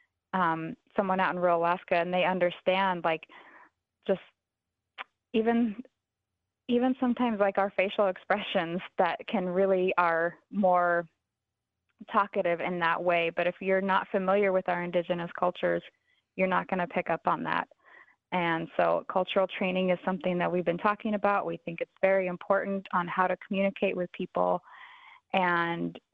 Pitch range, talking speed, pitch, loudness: 175-200 Hz, 155 wpm, 185 Hz, -29 LUFS